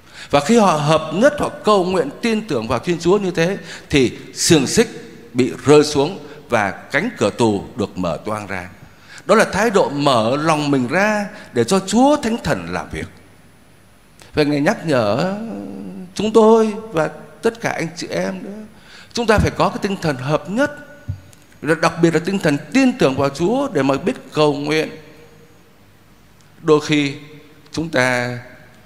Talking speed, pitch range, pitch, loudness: 175 wpm, 145-210 Hz, 160 Hz, -17 LUFS